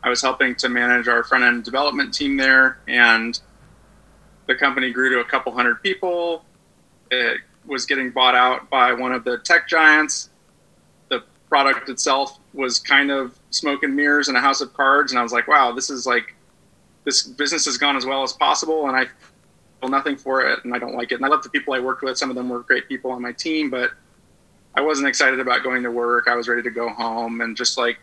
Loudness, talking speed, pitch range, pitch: -19 LUFS, 225 wpm, 125-145 Hz, 130 Hz